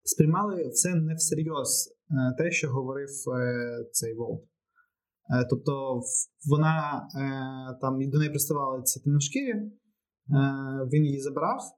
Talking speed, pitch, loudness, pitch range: 100 wpm, 145 Hz, -28 LUFS, 130-160 Hz